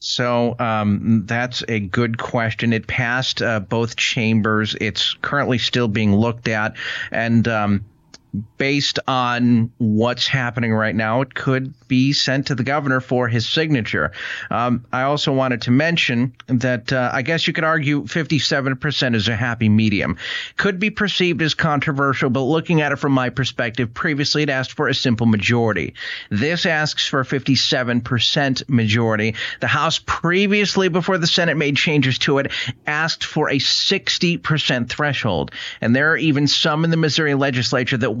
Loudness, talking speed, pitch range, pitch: -18 LUFS, 160 wpm, 115-150 Hz, 130 Hz